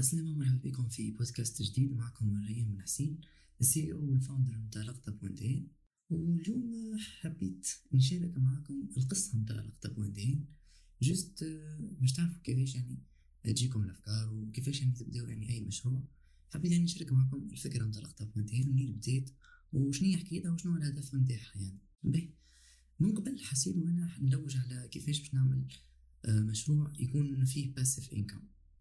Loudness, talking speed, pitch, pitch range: -35 LUFS, 145 wpm, 130 Hz, 110-150 Hz